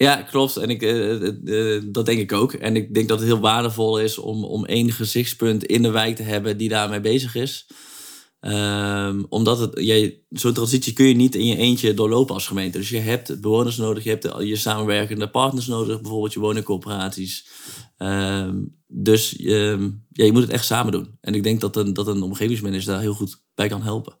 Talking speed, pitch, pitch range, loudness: 215 wpm, 110 Hz, 105-115 Hz, -21 LUFS